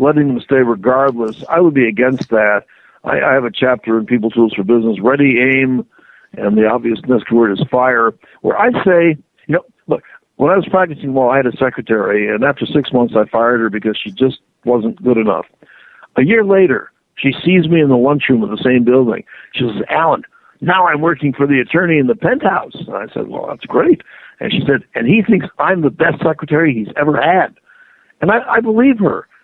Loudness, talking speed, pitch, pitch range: -14 LUFS, 215 wpm, 130 Hz, 115-170 Hz